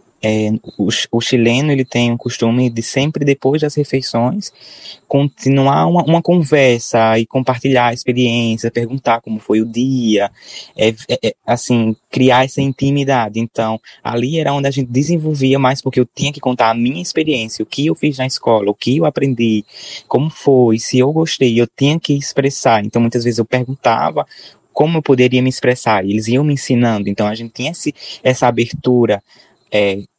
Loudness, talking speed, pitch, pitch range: -15 LUFS, 180 wpm, 125 Hz, 115-140 Hz